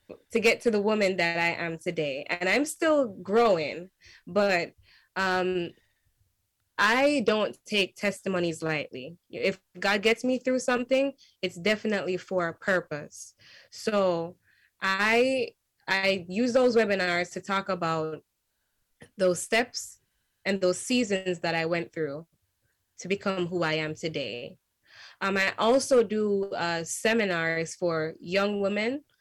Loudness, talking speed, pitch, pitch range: -27 LUFS, 130 wpm, 190 Hz, 170-215 Hz